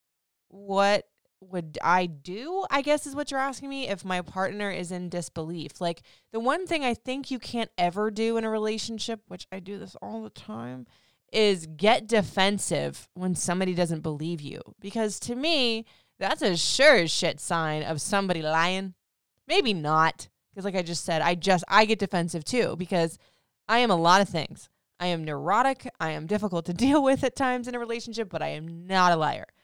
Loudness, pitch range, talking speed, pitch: -26 LUFS, 170-230 Hz, 195 wpm, 190 Hz